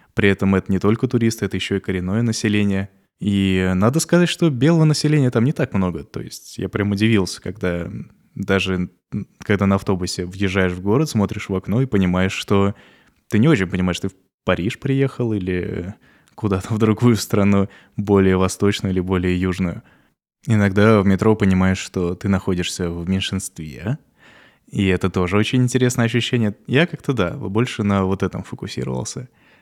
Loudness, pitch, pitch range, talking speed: -19 LUFS, 100 Hz, 95-110 Hz, 165 wpm